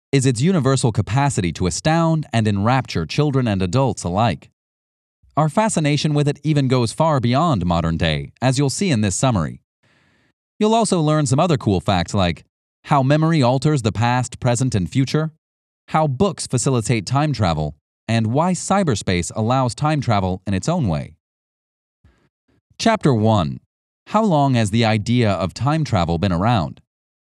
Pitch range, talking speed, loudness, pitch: 95-145 Hz, 155 wpm, -19 LUFS, 120 Hz